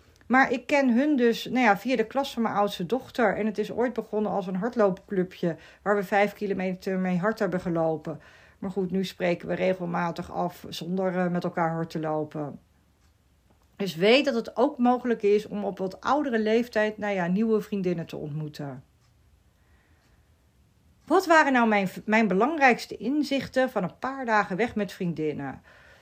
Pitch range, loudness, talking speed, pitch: 175-230 Hz, -26 LUFS, 175 wpm, 200 Hz